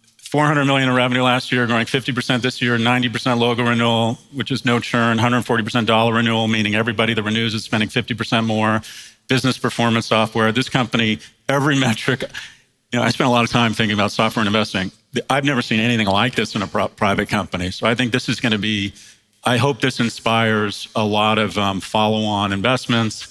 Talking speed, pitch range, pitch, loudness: 200 wpm, 110-125 Hz, 115 Hz, -18 LUFS